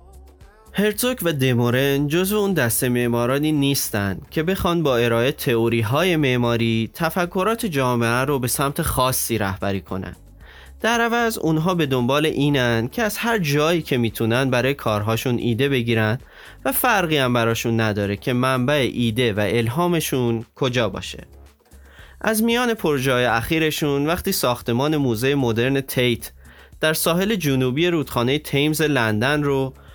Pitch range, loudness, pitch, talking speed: 115-155 Hz, -20 LUFS, 130 Hz, 135 wpm